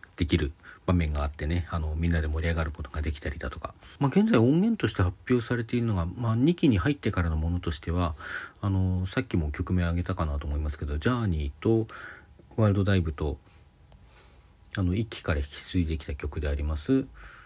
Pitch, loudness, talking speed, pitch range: 90 Hz, -28 LUFS, 410 characters per minute, 80-110 Hz